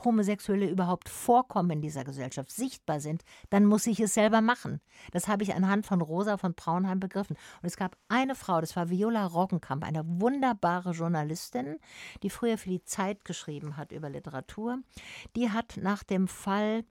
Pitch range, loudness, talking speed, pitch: 165-215 Hz, -30 LUFS, 175 wpm, 190 Hz